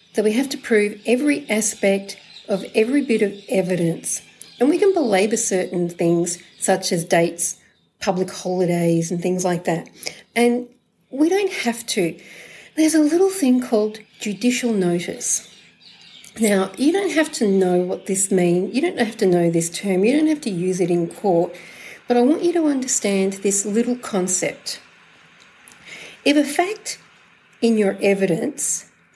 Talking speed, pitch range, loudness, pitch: 165 wpm, 185-250 Hz, -20 LUFS, 205 Hz